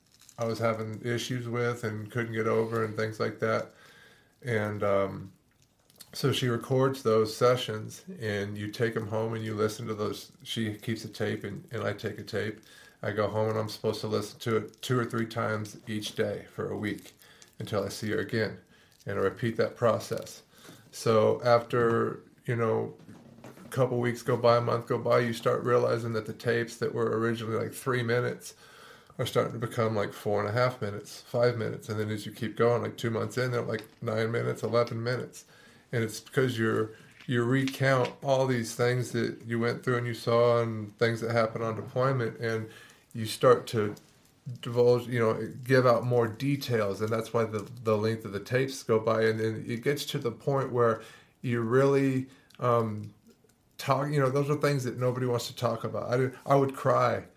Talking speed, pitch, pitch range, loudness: 205 wpm, 115 Hz, 110-125 Hz, -29 LUFS